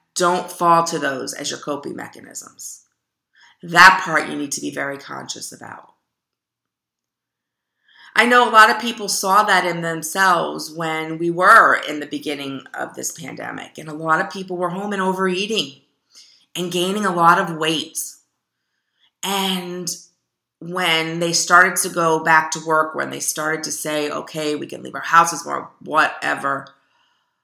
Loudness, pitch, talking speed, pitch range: -18 LUFS, 170 Hz, 160 wpm, 155-190 Hz